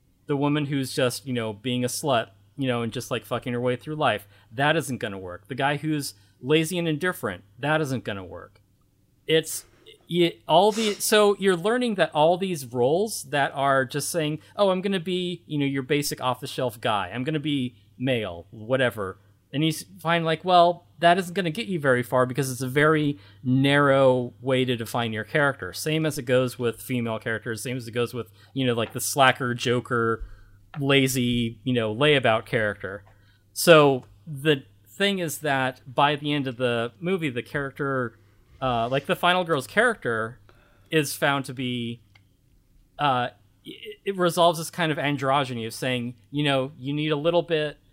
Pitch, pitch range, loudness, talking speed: 135 Hz, 120-155 Hz, -24 LUFS, 190 wpm